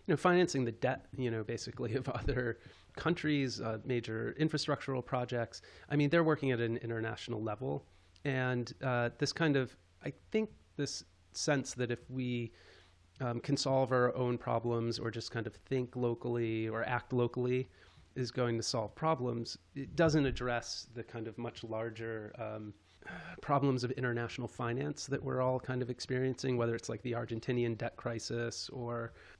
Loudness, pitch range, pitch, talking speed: -36 LUFS, 115-130 Hz, 120 Hz, 175 wpm